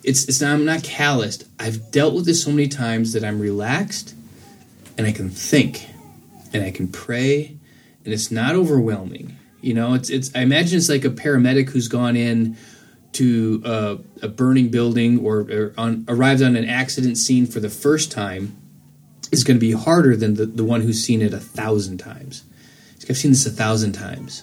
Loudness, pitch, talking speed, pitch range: -19 LUFS, 120 Hz, 195 wpm, 110-135 Hz